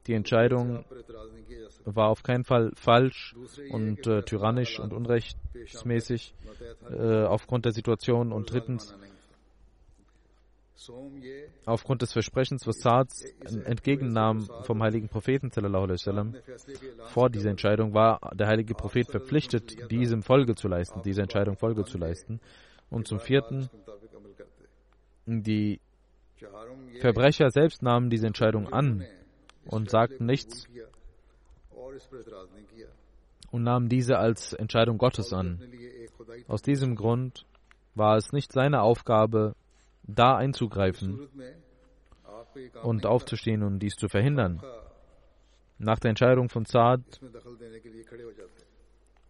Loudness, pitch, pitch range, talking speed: -27 LUFS, 115 Hz, 110-125 Hz, 105 wpm